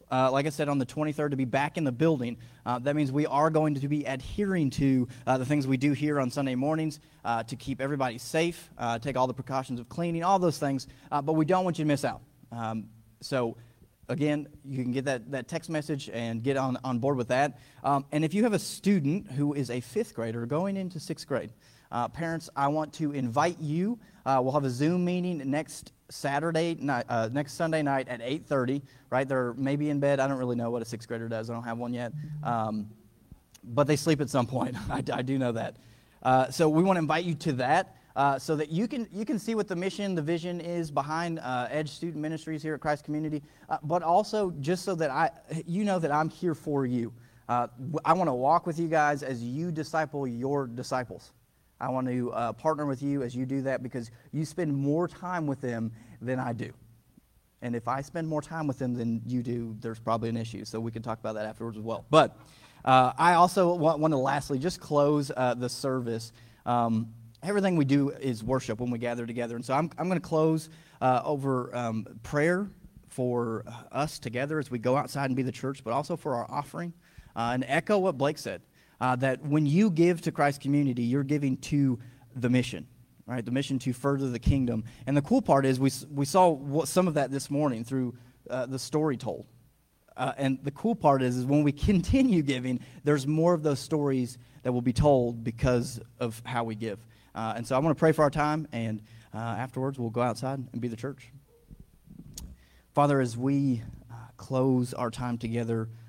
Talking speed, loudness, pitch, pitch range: 225 wpm, -29 LUFS, 135 Hz, 125-155 Hz